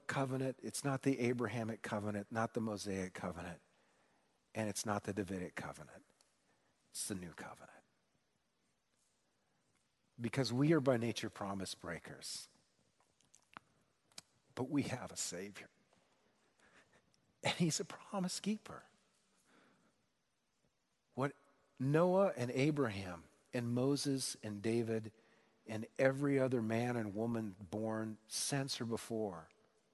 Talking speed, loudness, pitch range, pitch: 110 wpm, -39 LUFS, 105-135 Hz, 115 Hz